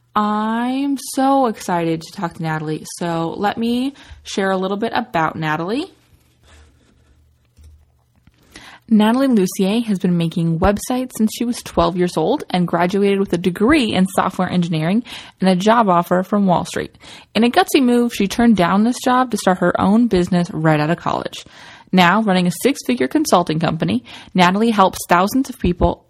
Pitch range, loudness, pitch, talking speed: 170-230 Hz, -17 LUFS, 190 Hz, 165 wpm